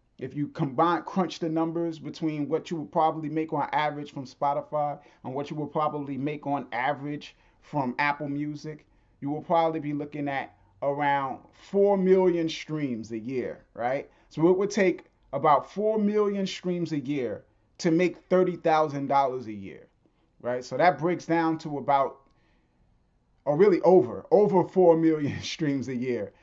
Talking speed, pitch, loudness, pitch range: 165 wpm, 150 Hz, -27 LUFS, 140-170 Hz